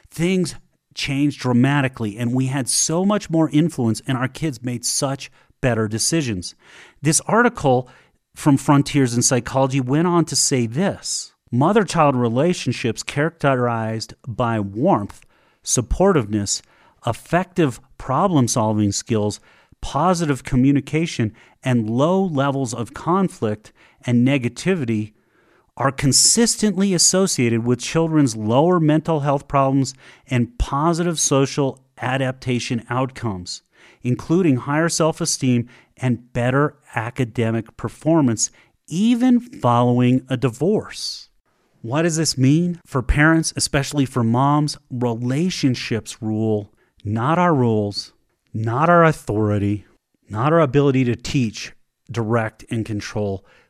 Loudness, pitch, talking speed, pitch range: -19 LUFS, 130 Hz, 110 wpm, 120-155 Hz